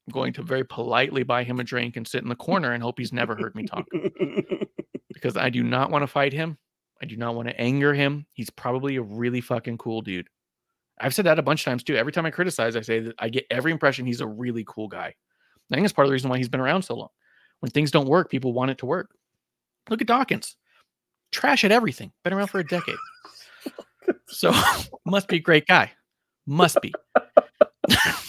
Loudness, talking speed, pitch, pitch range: -24 LUFS, 230 wpm, 130 Hz, 120-160 Hz